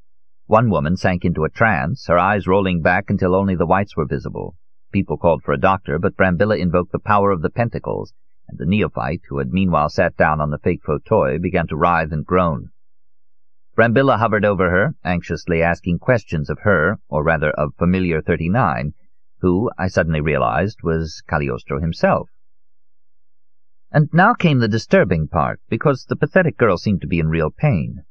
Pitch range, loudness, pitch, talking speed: 80-100 Hz, -18 LUFS, 90 Hz, 180 wpm